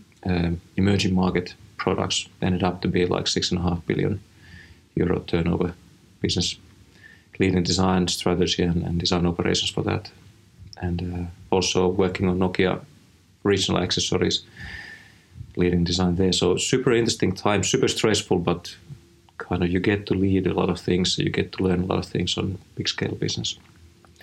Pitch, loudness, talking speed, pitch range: 90 Hz, -23 LUFS, 165 wpm, 90-95 Hz